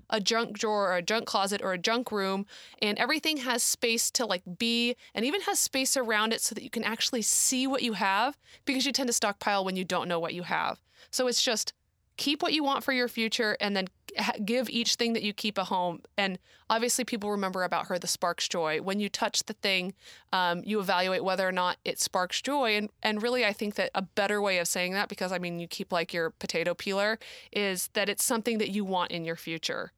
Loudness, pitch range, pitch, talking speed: -29 LUFS, 185-235 Hz, 210 Hz, 240 wpm